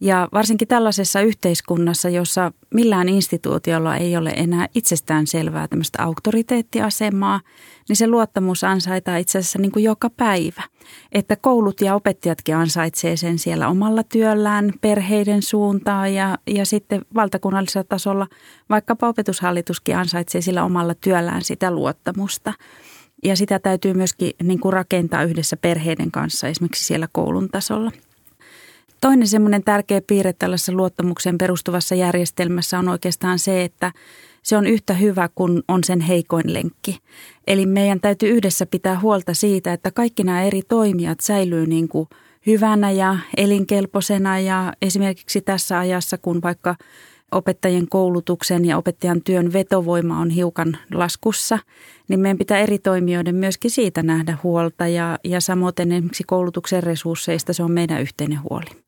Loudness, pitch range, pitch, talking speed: -19 LUFS, 175-205 Hz, 185 Hz, 140 wpm